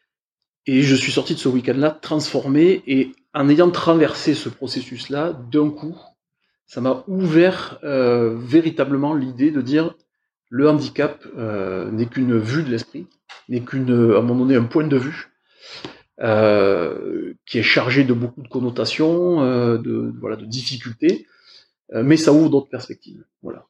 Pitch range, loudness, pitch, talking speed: 125-155 Hz, -19 LUFS, 135 Hz, 155 wpm